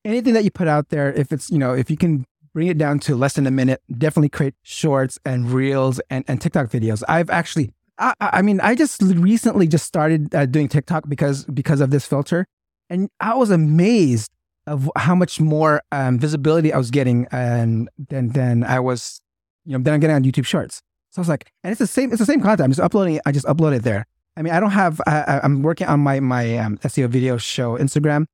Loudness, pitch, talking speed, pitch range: -19 LUFS, 145 Hz, 235 wpm, 130-165 Hz